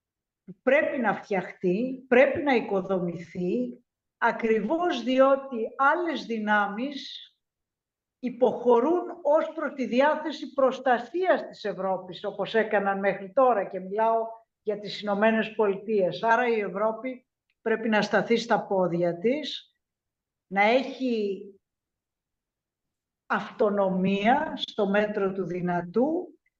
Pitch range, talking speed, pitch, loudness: 200-265 Hz, 100 wpm, 225 Hz, -26 LUFS